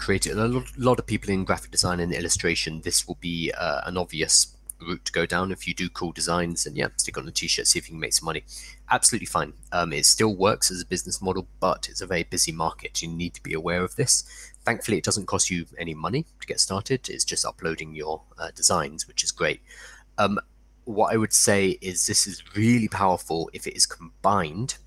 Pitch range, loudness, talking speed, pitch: 85-100 Hz, -24 LUFS, 230 wpm, 90 Hz